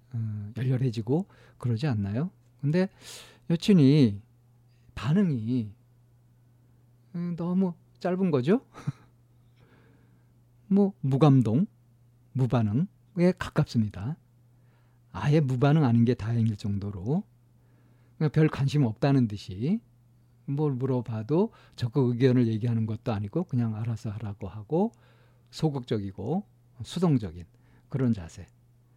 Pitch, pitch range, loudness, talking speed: 120 Hz, 120-145 Hz, -27 LUFS, 220 characters per minute